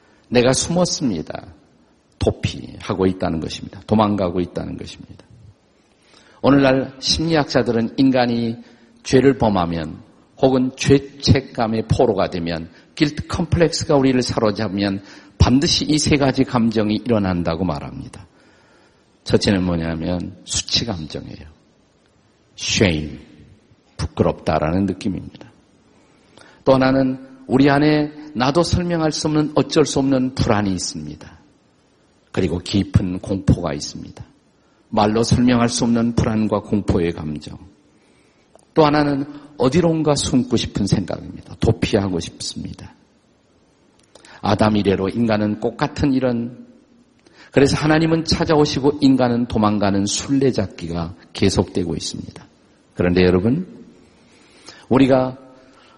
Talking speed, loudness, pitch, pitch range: 270 characters per minute, -19 LUFS, 115 Hz, 95-135 Hz